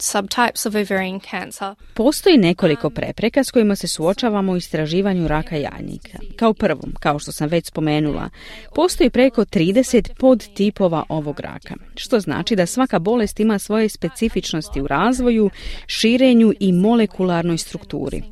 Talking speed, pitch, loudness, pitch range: 125 wpm, 200 Hz, -18 LUFS, 170-225 Hz